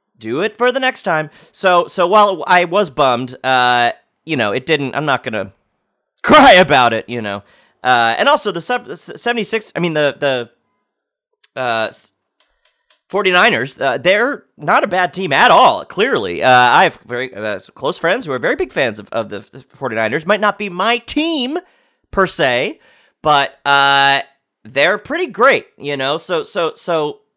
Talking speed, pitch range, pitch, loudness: 175 wpm, 130-210 Hz, 160 Hz, -14 LUFS